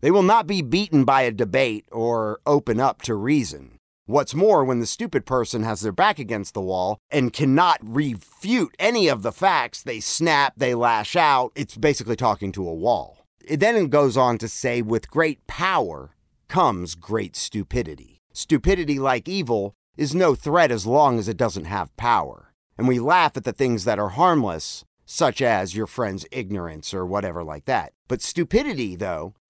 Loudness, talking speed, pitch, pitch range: -22 LUFS, 185 wpm, 125 Hz, 110-150 Hz